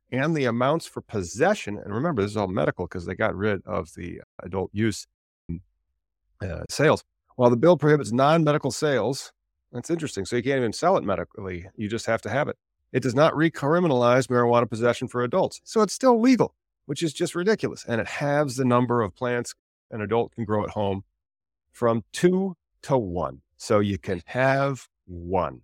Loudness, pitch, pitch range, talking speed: -24 LUFS, 120 Hz, 95-140 Hz, 190 wpm